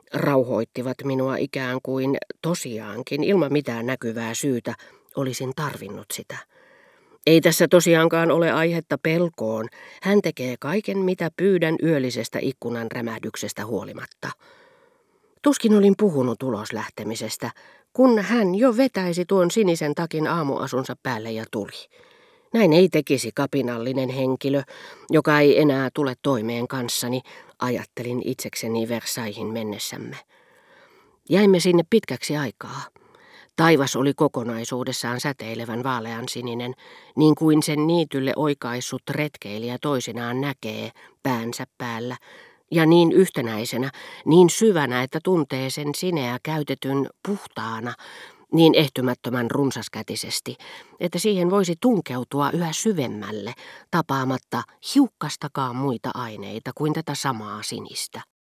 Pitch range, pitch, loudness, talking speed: 120-165 Hz, 140 Hz, -23 LUFS, 110 wpm